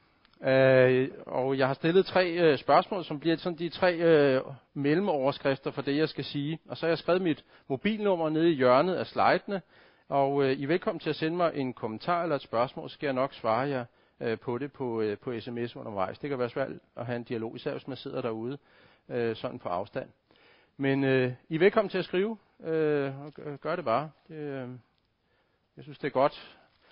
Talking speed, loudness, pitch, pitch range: 215 wpm, -29 LUFS, 140 Hz, 130-165 Hz